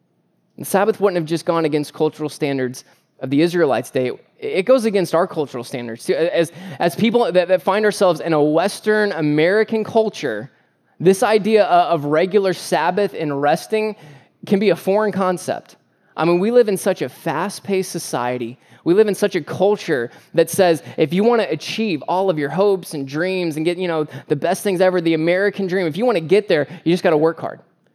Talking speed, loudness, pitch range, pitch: 200 wpm, -18 LUFS, 155-200 Hz, 175 Hz